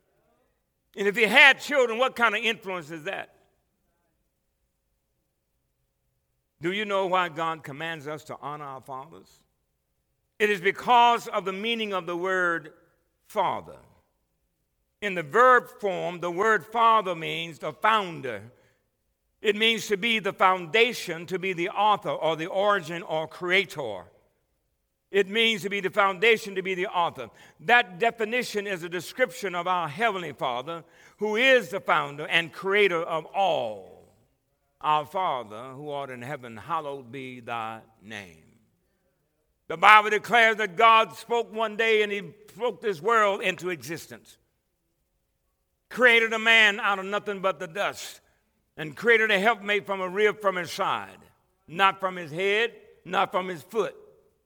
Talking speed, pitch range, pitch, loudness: 150 wpm, 160-215 Hz, 190 Hz, -24 LUFS